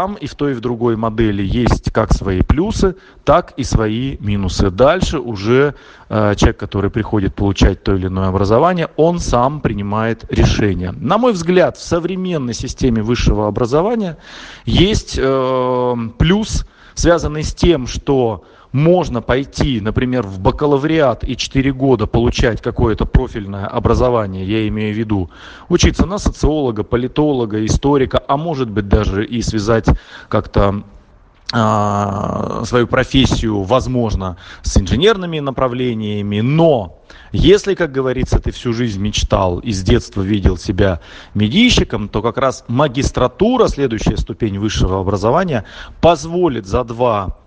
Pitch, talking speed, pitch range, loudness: 115 Hz, 130 wpm, 105-135 Hz, -16 LUFS